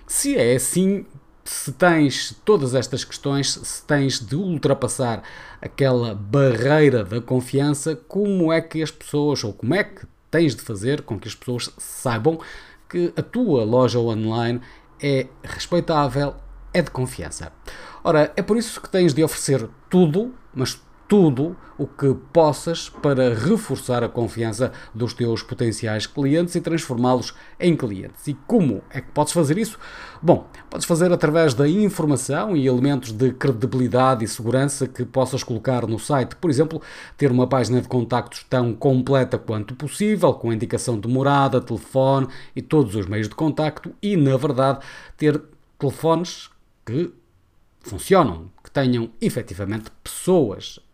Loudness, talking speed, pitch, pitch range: -21 LUFS, 150 wpm, 135 Hz, 125-155 Hz